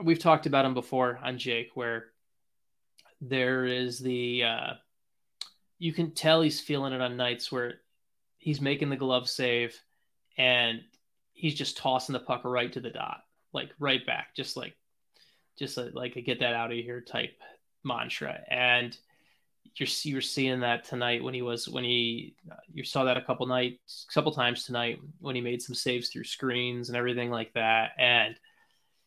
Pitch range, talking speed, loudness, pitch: 120-135 Hz, 175 wpm, -29 LUFS, 125 Hz